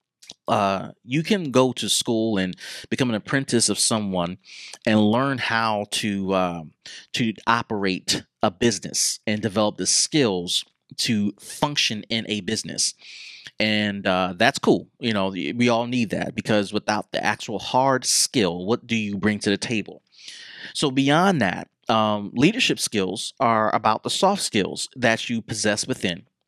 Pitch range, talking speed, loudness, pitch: 105-125 Hz, 155 wpm, -22 LUFS, 110 Hz